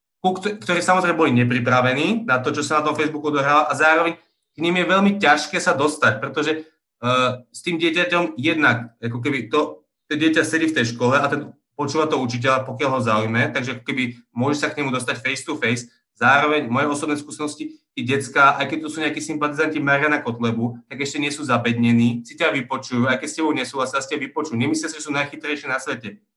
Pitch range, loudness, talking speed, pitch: 125-155 Hz, -20 LUFS, 205 wpm, 145 Hz